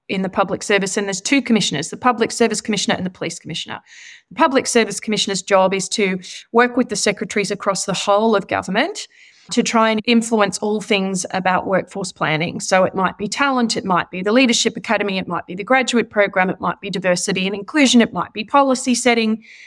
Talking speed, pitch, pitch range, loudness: 210 wpm, 210 Hz, 195-235 Hz, -18 LUFS